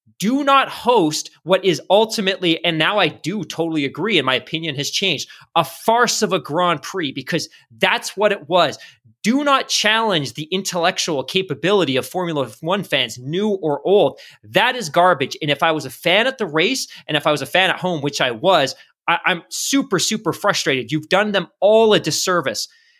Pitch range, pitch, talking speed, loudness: 155-205 Hz, 175 Hz, 195 wpm, -18 LUFS